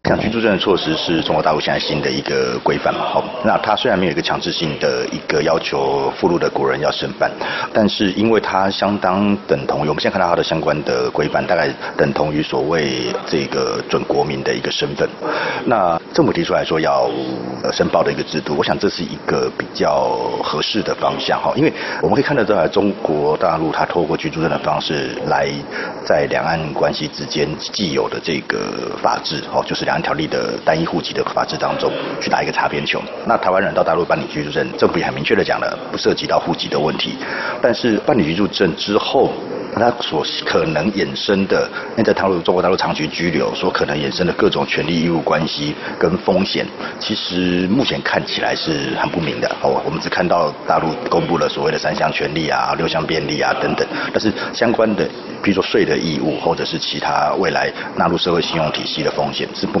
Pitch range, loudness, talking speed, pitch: 75-100 Hz, -18 LUFS, 325 characters per minute, 90 Hz